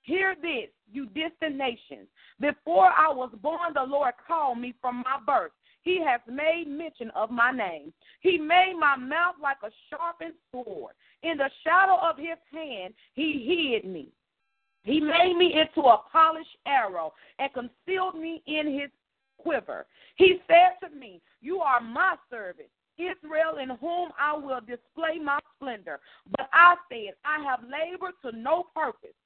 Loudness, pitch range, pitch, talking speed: -25 LUFS, 265-345 Hz, 310 Hz, 160 wpm